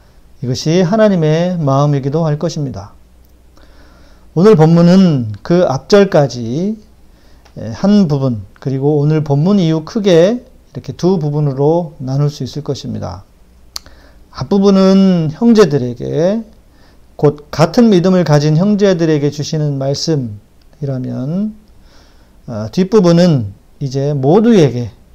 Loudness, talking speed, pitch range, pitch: -12 LUFS, 235 characters per minute, 125-180 Hz, 150 Hz